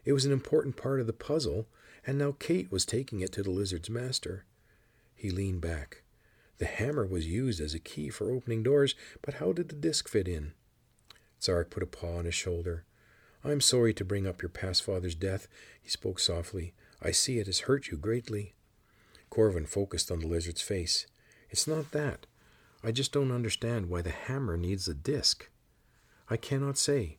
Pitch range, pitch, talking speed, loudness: 90-130 Hz, 110 Hz, 190 wpm, -32 LUFS